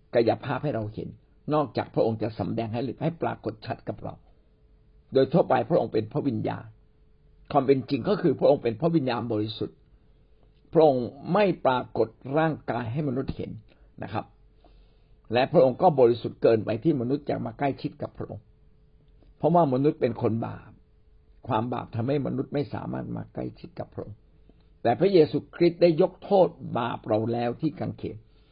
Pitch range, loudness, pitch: 110-150 Hz, -26 LUFS, 125 Hz